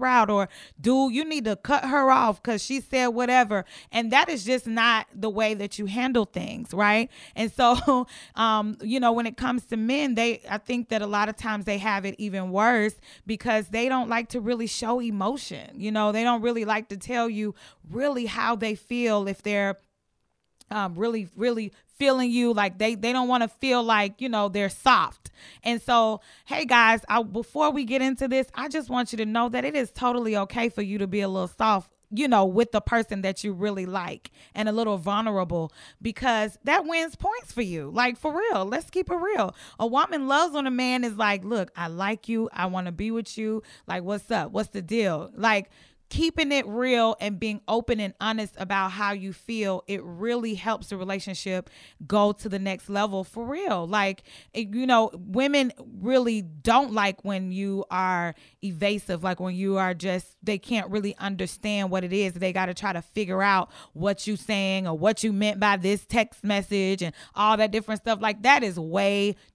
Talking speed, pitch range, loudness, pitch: 210 wpm, 200-240 Hz, -25 LUFS, 215 Hz